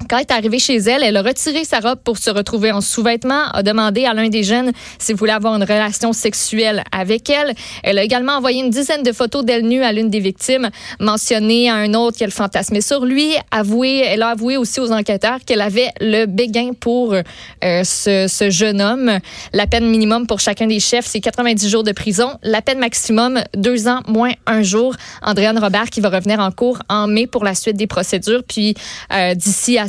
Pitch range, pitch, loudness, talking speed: 210-245 Hz, 225 Hz, -15 LUFS, 220 wpm